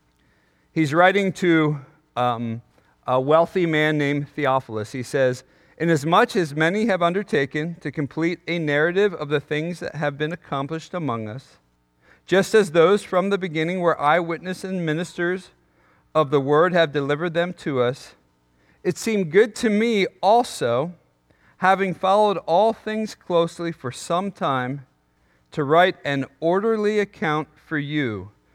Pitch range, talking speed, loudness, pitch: 140-180 Hz, 145 wpm, -22 LUFS, 160 Hz